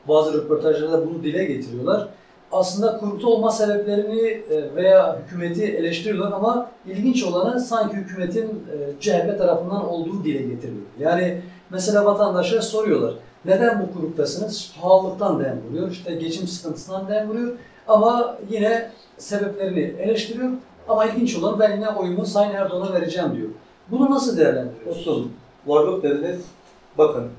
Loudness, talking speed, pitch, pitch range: -21 LUFS, 125 wpm, 195 Hz, 170-220 Hz